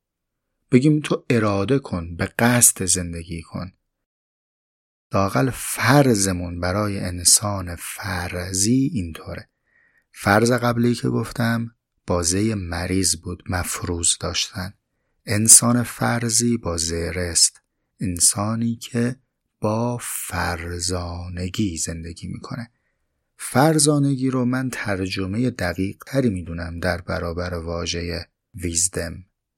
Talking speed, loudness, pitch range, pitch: 90 wpm, -20 LUFS, 85-120 Hz, 95 Hz